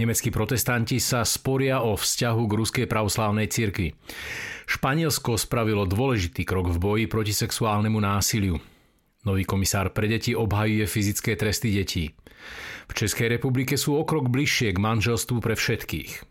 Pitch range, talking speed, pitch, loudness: 105-120 Hz, 135 wpm, 110 Hz, -24 LUFS